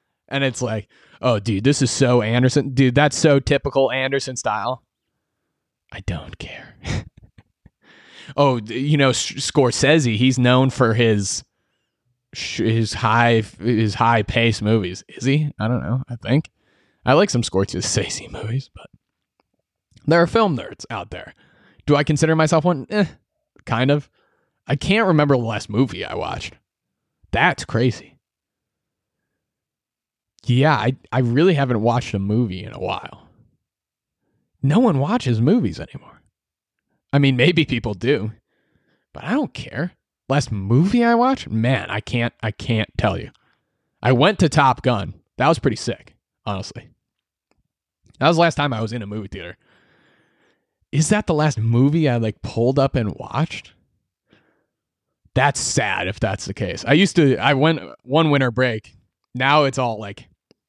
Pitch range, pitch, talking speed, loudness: 110-145 Hz, 125 Hz, 150 wpm, -19 LUFS